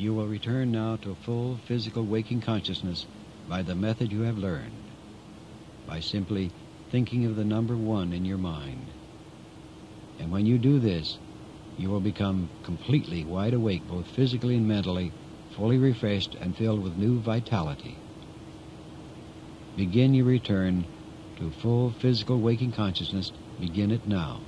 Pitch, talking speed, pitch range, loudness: 105 Hz, 145 wpm, 95-120 Hz, -28 LUFS